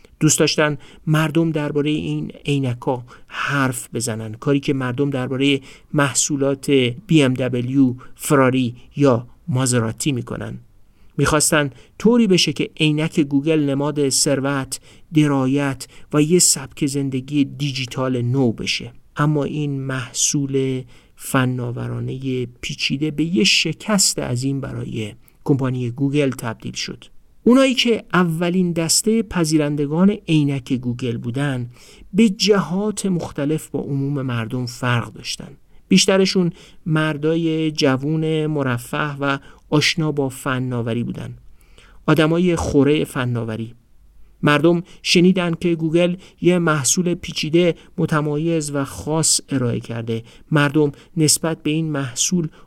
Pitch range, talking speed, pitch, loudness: 130-160 Hz, 110 wpm, 145 Hz, -19 LUFS